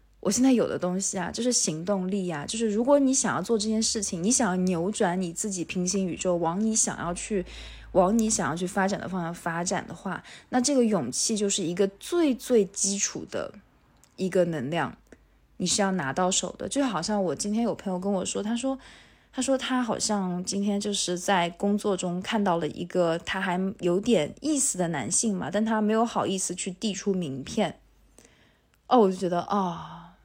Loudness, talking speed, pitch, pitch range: -26 LUFS, 285 characters per minute, 195 Hz, 180-220 Hz